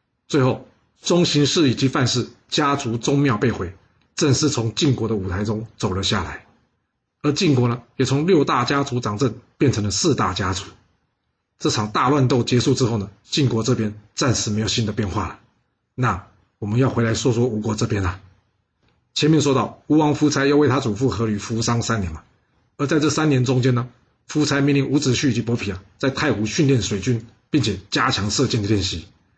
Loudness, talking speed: -20 LUFS, 285 characters per minute